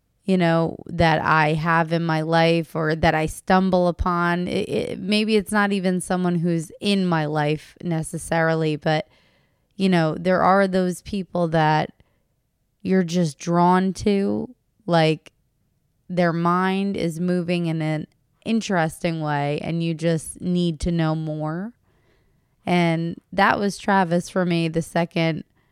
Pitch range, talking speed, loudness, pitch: 155-180 Hz, 140 wpm, -22 LUFS, 170 Hz